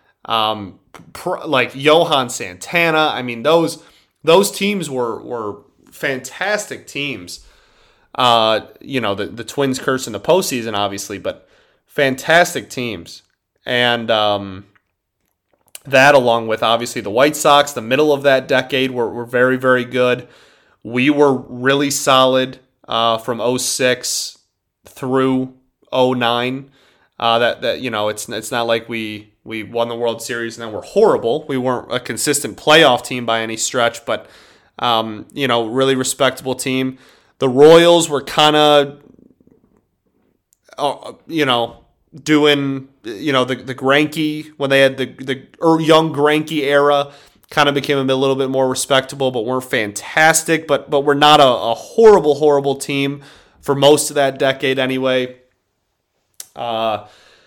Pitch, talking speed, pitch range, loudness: 130 Hz, 145 wpm, 115-145 Hz, -16 LUFS